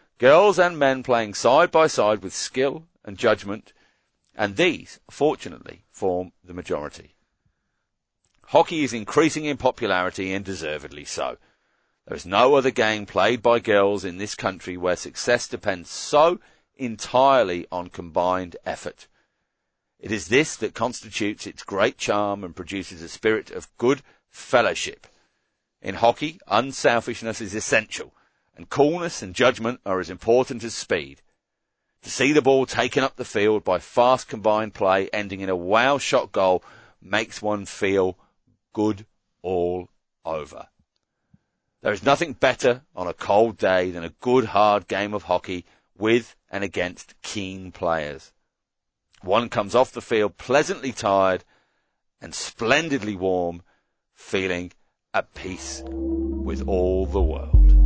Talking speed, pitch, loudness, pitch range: 140 wpm, 100 Hz, -23 LUFS, 90-120 Hz